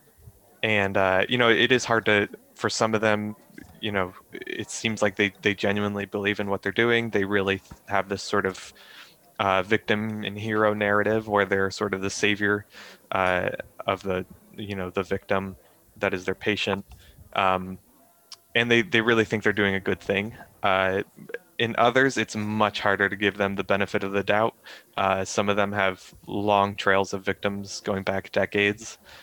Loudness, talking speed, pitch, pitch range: -25 LUFS, 185 wpm, 100 Hz, 95-105 Hz